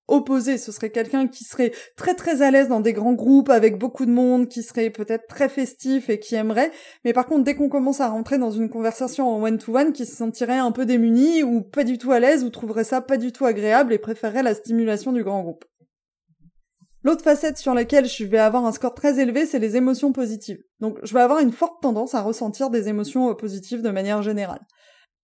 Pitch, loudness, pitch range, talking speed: 245 Hz, -21 LUFS, 225-270 Hz, 230 wpm